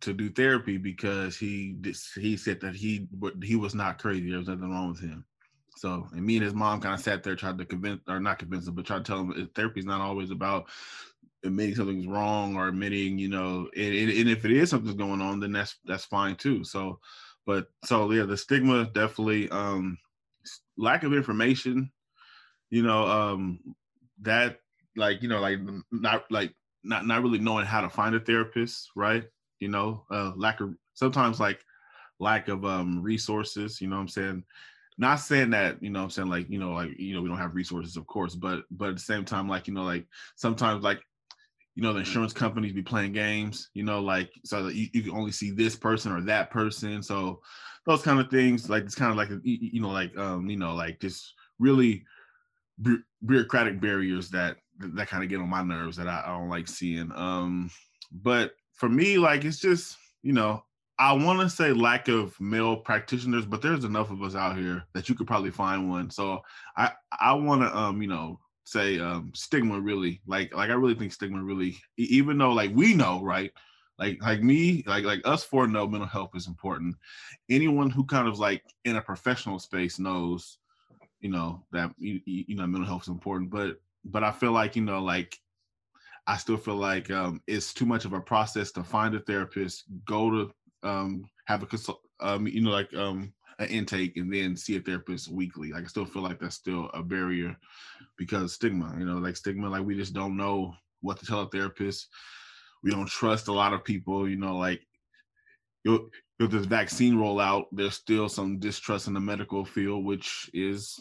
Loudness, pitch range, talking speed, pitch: -28 LUFS, 95-110 Hz, 205 wpm, 100 Hz